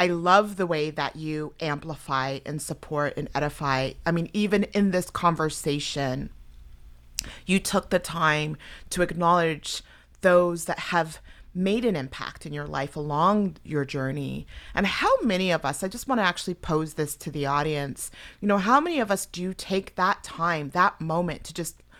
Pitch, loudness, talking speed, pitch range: 160 Hz, -26 LUFS, 175 wpm, 145-185 Hz